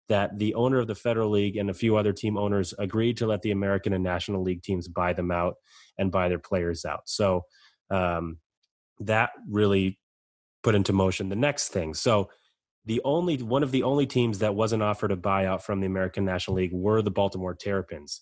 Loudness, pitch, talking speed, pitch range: -27 LUFS, 100 Hz, 205 wpm, 90-110 Hz